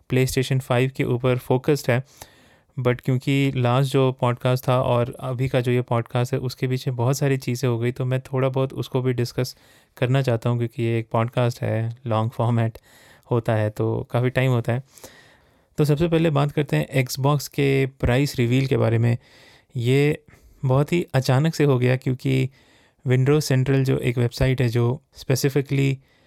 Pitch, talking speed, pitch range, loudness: 130 Hz, 185 wpm, 120-135 Hz, -22 LUFS